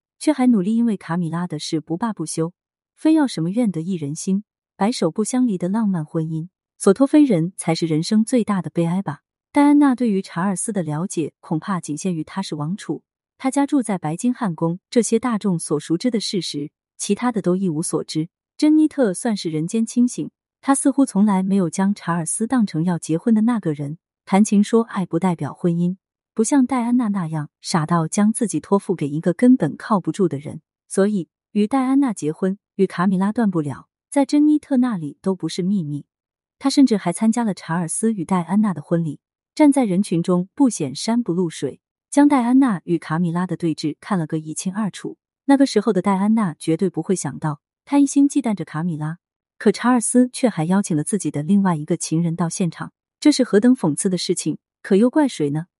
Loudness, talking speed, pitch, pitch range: -20 LUFS, 310 characters per minute, 190 Hz, 165-230 Hz